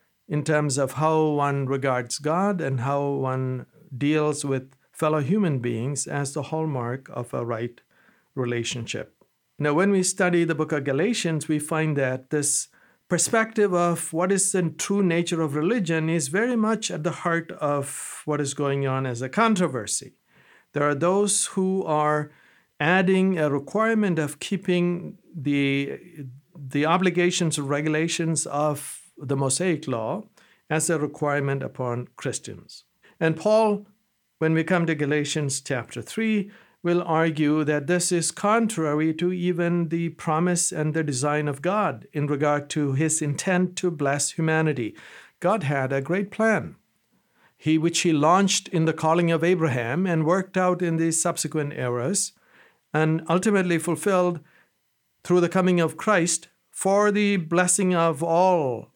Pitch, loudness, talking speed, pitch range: 160 Hz, -24 LUFS, 150 wpm, 145-180 Hz